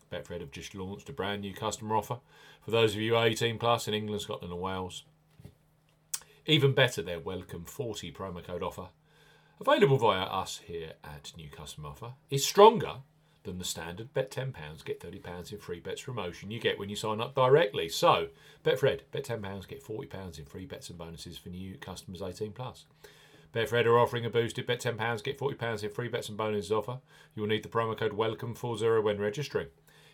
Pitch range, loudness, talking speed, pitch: 105-140 Hz, -30 LUFS, 190 wpm, 115 Hz